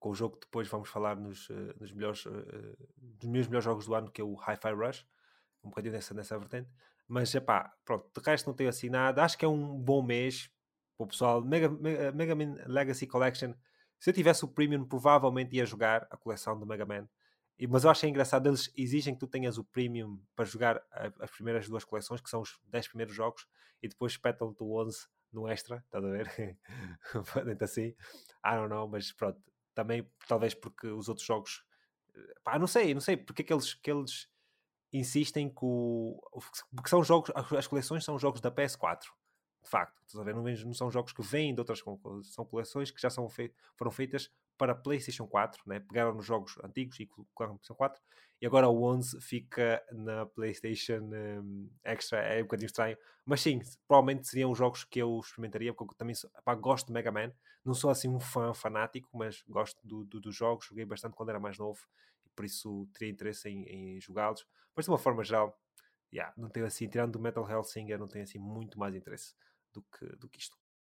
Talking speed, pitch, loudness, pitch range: 210 wpm, 115 Hz, -34 LUFS, 110-130 Hz